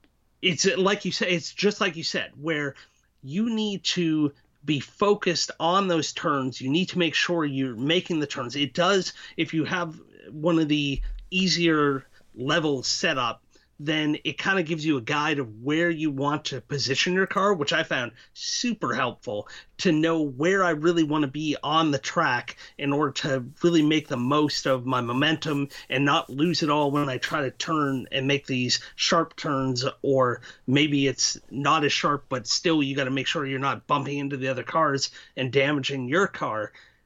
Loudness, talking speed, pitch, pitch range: -25 LUFS, 195 wpm, 150 Hz, 140-170 Hz